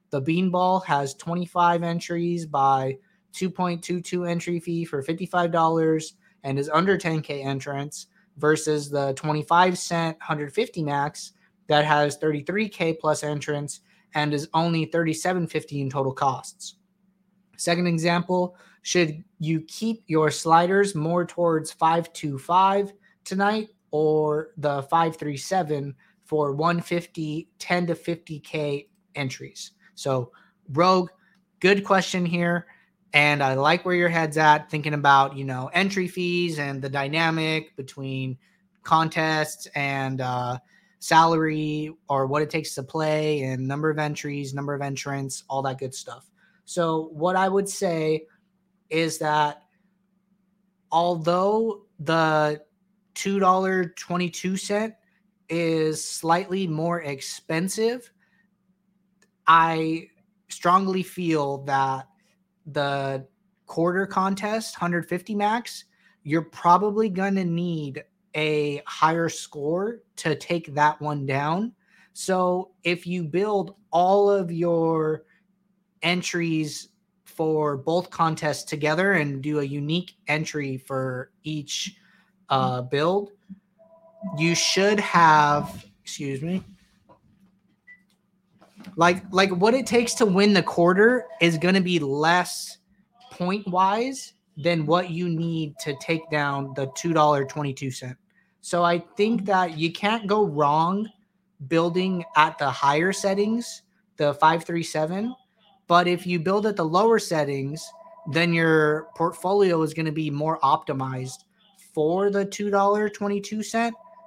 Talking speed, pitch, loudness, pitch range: 115 wpm, 170 Hz, -24 LUFS, 150-195 Hz